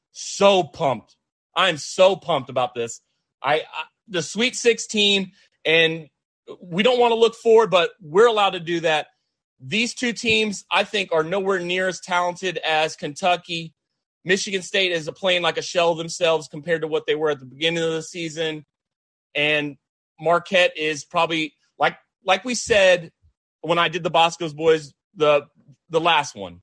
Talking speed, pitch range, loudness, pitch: 175 wpm, 155-195 Hz, -21 LUFS, 170 Hz